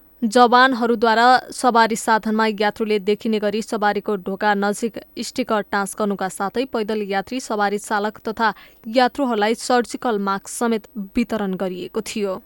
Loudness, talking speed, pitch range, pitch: -20 LUFS, 115 wpm, 205-240 Hz, 220 Hz